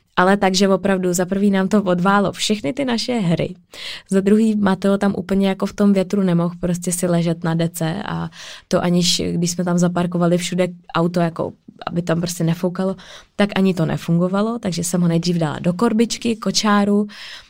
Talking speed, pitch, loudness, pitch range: 180 wpm, 185 Hz, -19 LUFS, 175-200 Hz